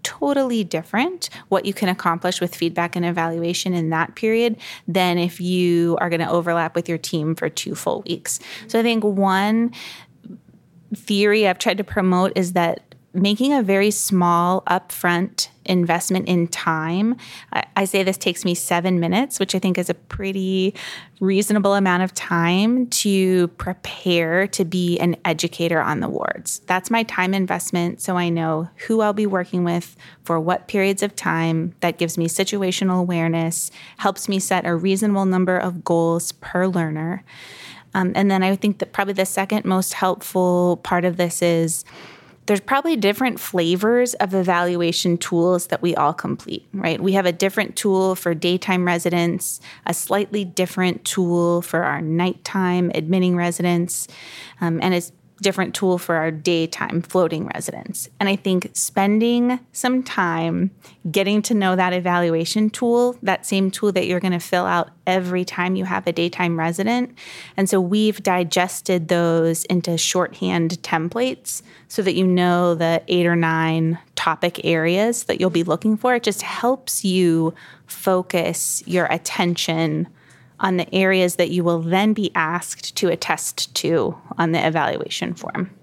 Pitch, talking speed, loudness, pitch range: 180 Hz, 160 wpm, -20 LUFS, 170-195 Hz